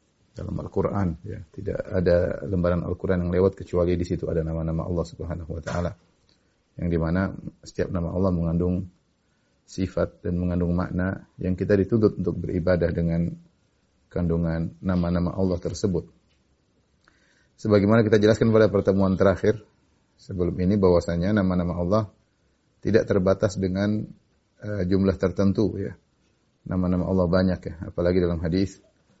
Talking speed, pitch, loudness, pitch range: 130 wpm, 90 Hz, -24 LUFS, 85-100 Hz